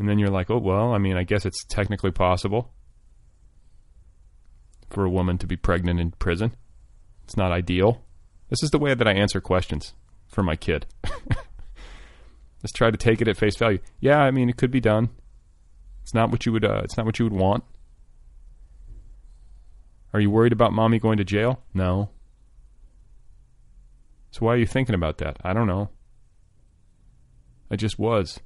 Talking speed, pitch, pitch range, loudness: 175 wpm, 100 Hz, 90-115 Hz, -23 LUFS